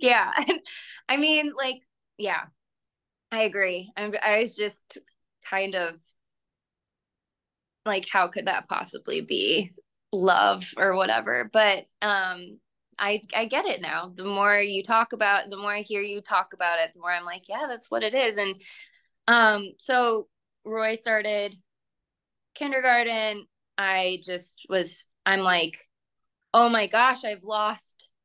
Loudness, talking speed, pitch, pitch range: -24 LUFS, 140 wpm, 210 Hz, 195-230 Hz